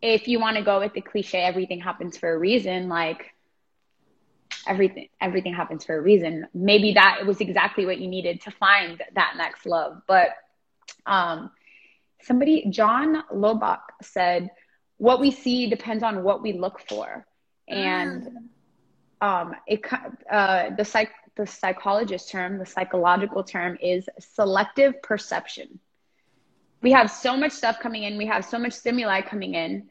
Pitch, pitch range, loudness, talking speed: 205 Hz, 185-225 Hz, -23 LUFS, 155 wpm